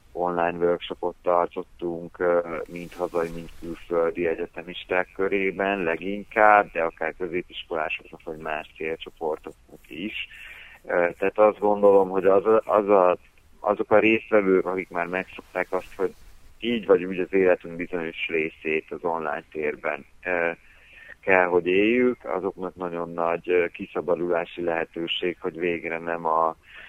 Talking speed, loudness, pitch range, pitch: 120 wpm, -24 LUFS, 85-95 Hz, 90 Hz